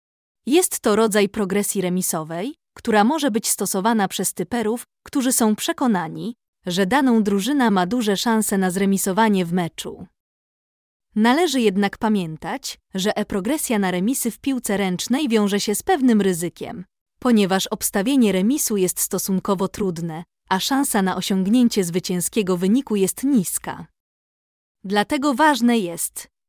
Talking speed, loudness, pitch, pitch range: 125 wpm, -20 LUFS, 205 Hz, 190-240 Hz